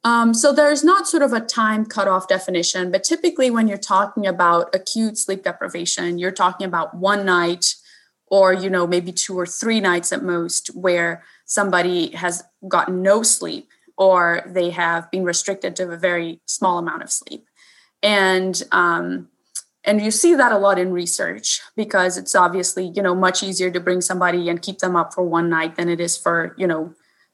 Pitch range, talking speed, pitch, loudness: 175-200 Hz, 185 wpm, 185 Hz, -19 LUFS